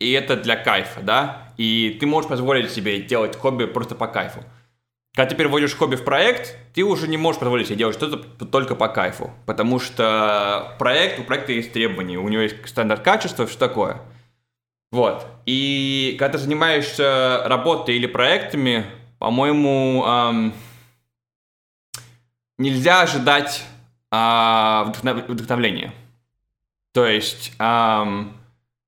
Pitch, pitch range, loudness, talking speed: 120 Hz, 110-135 Hz, -20 LUFS, 125 wpm